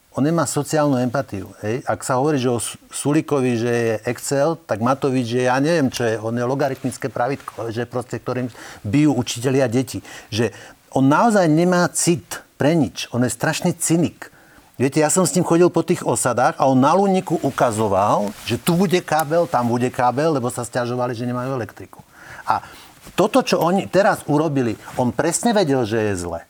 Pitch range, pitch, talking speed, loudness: 120-165 Hz, 135 Hz, 185 wpm, -19 LUFS